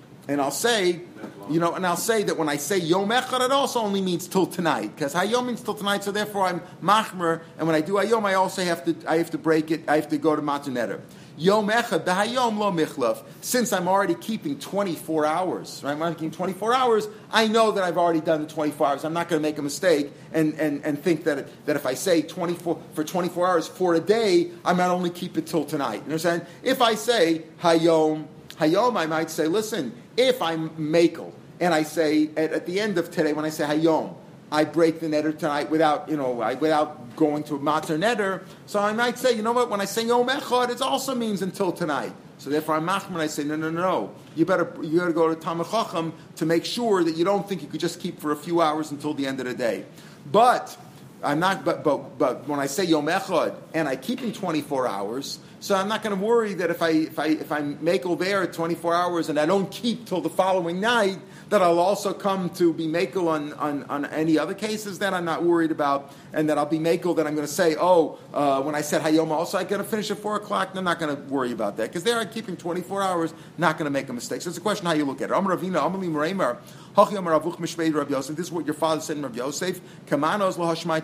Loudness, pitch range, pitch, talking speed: -24 LUFS, 155-195 Hz, 170 Hz, 245 wpm